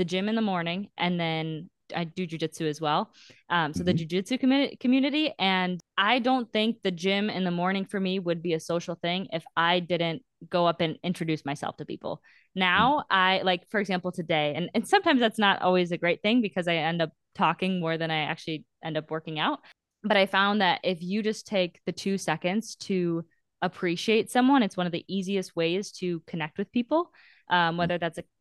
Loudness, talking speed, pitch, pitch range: -27 LUFS, 210 wpm, 180 Hz, 170-200 Hz